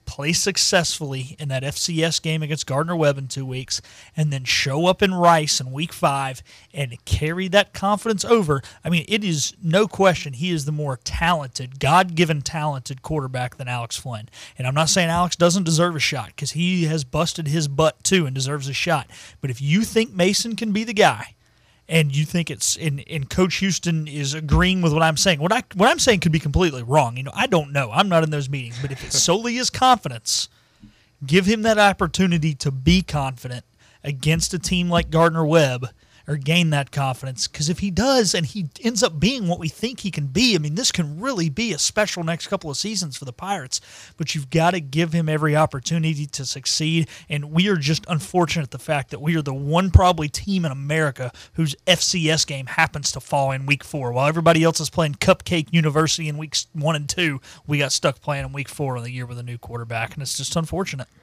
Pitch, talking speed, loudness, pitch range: 155 Hz, 220 wpm, -21 LUFS, 140-175 Hz